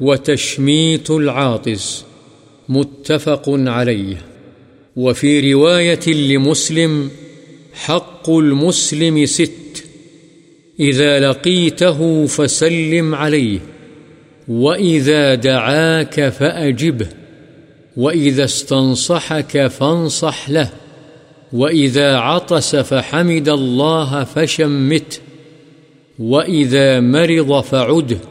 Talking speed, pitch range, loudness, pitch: 60 wpm, 140-160 Hz, -14 LUFS, 150 Hz